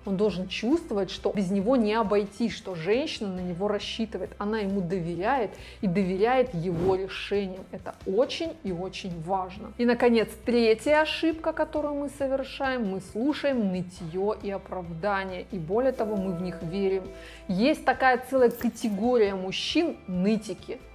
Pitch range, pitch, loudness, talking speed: 190-250 Hz, 210 Hz, -27 LUFS, 145 wpm